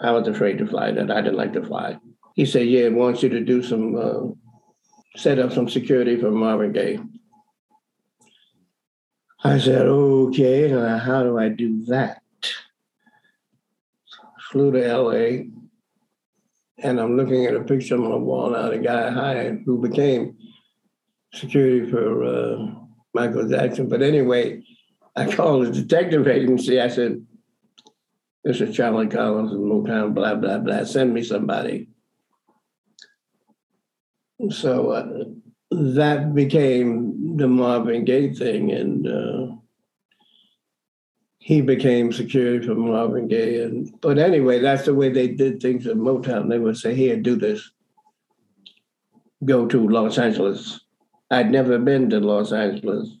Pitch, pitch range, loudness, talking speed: 130 Hz, 120-155 Hz, -20 LUFS, 140 wpm